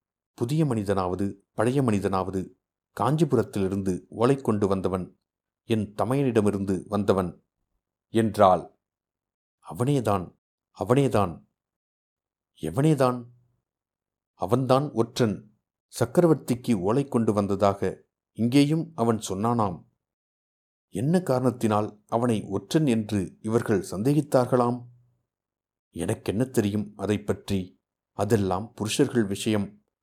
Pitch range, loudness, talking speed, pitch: 100-125 Hz, -25 LUFS, 75 wpm, 110 Hz